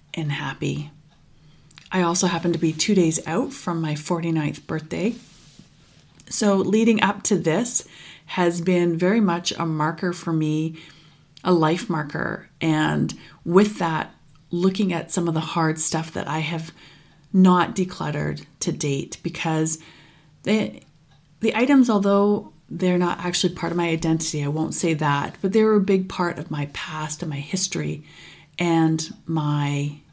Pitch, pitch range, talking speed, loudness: 165 Hz, 155-180 Hz, 155 wpm, -22 LUFS